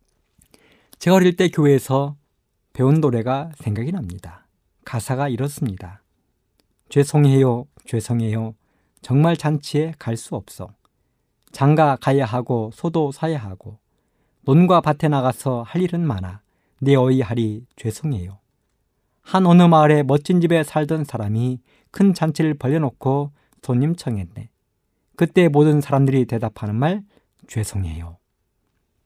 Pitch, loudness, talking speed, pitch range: 135 Hz, -19 LUFS, 255 characters per minute, 110-155 Hz